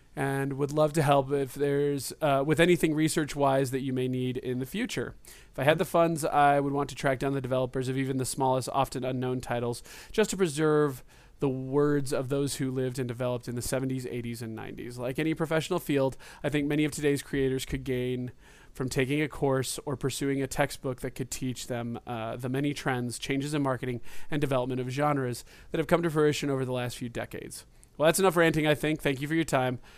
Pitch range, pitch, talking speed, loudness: 130-150 Hz, 135 Hz, 220 wpm, -29 LUFS